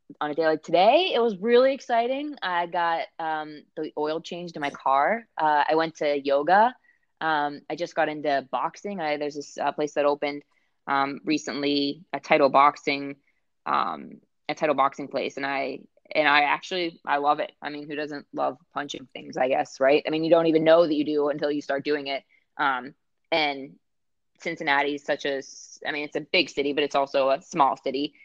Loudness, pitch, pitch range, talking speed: -25 LUFS, 150 Hz, 140-165 Hz, 205 wpm